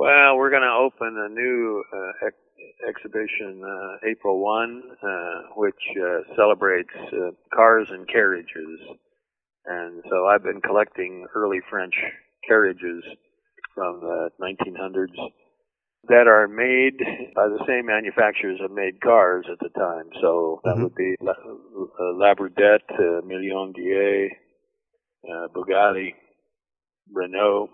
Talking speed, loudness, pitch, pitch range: 125 wpm, -21 LUFS, 105 Hz, 95-135 Hz